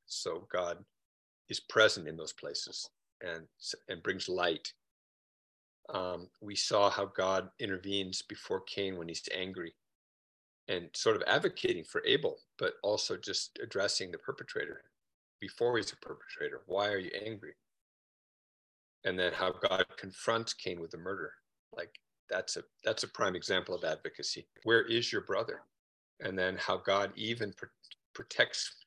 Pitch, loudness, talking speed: 105 Hz, -35 LUFS, 150 wpm